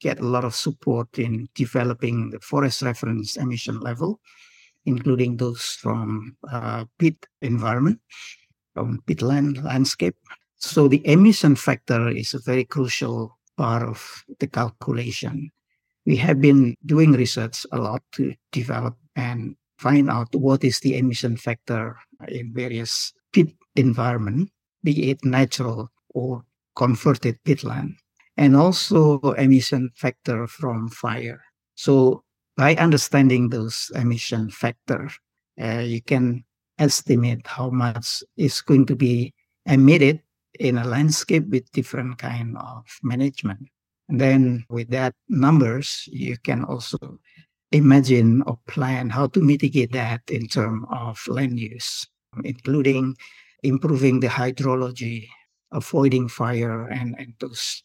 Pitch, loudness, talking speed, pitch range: 130 Hz, -21 LUFS, 125 wpm, 120-140 Hz